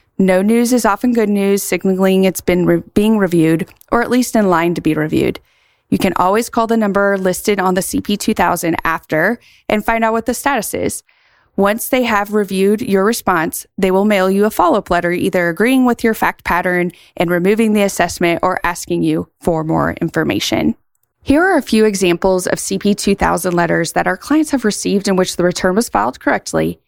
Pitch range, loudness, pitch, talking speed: 175-220 Hz, -15 LUFS, 195 Hz, 195 wpm